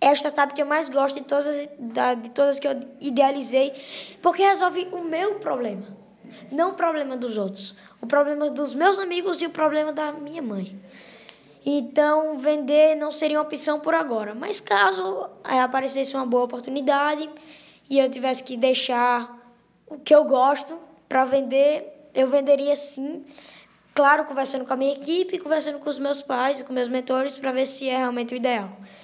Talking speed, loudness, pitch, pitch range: 175 wpm, -23 LUFS, 280 Hz, 255-300 Hz